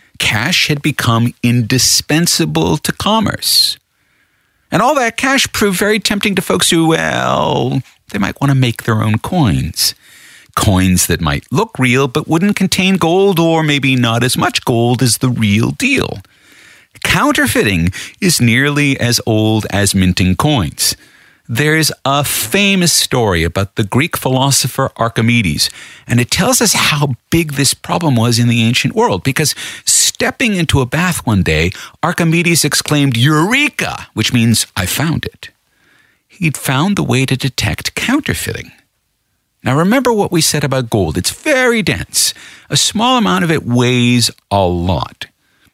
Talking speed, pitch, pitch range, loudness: 150 wpm, 135 Hz, 115-165 Hz, -13 LUFS